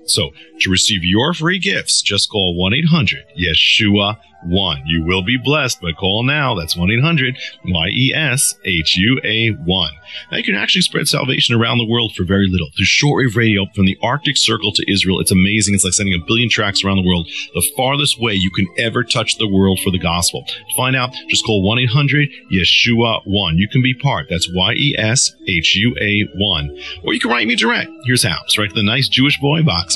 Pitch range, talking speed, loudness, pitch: 95-130 Hz, 225 wpm, -14 LUFS, 105 Hz